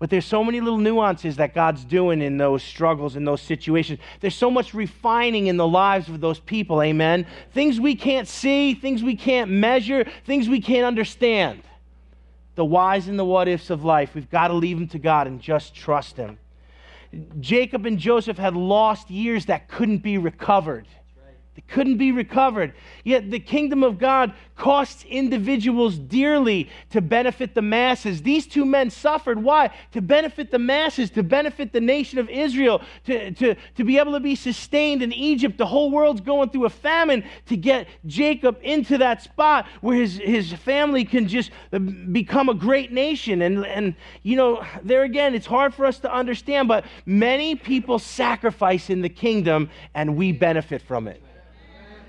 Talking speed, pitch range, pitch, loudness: 175 wpm, 175-260 Hz, 230 Hz, -21 LUFS